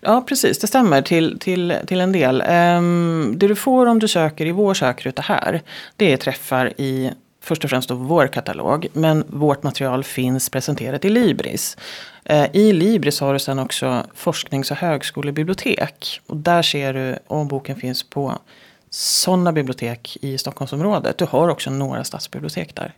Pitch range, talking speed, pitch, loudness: 135-180 Hz, 165 wpm, 150 Hz, -19 LUFS